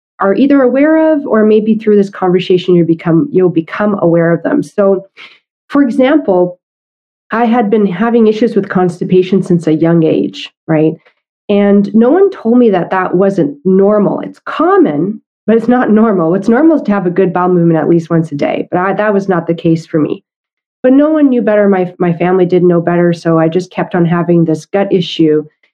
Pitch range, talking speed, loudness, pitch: 170-220 Hz, 205 wpm, -11 LUFS, 185 Hz